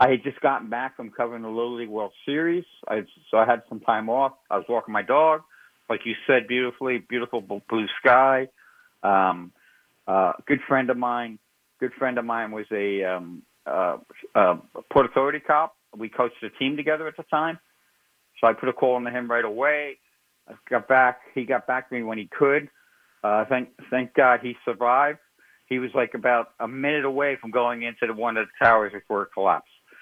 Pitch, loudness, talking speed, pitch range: 125 Hz, -24 LUFS, 205 wpm, 115-140 Hz